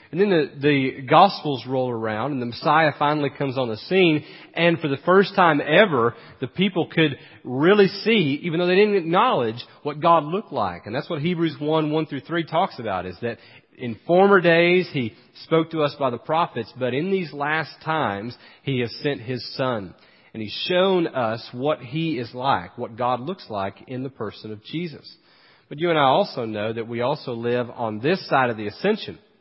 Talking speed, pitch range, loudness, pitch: 205 wpm, 120-170 Hz, -22 LUFS, 145 Hz